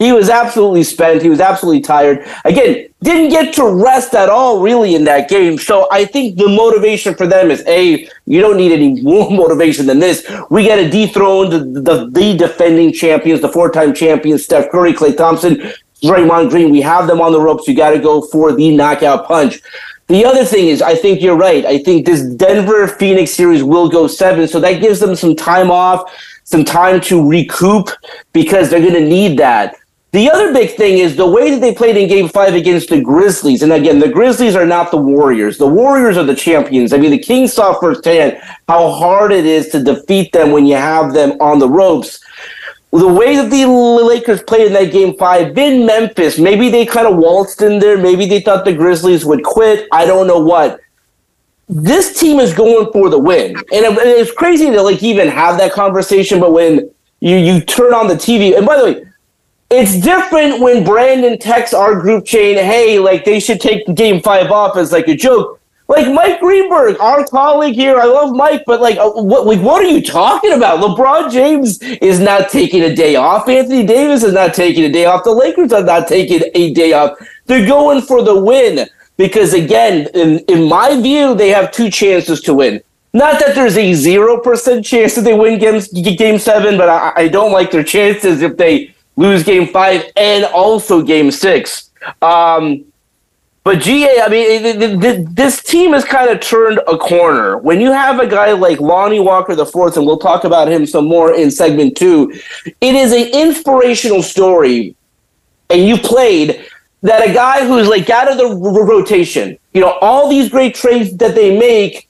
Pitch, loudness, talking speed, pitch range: 200 Hz, -9 LUFS, 200 wpm, 170-240 Hz